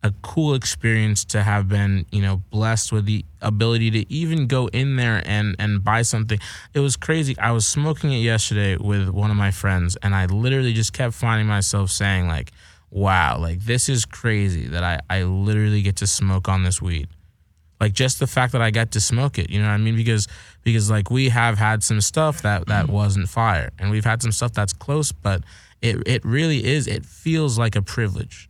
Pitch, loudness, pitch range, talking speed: 105 Hz, -21 LUFS, 95-115 Hz, 215 wpm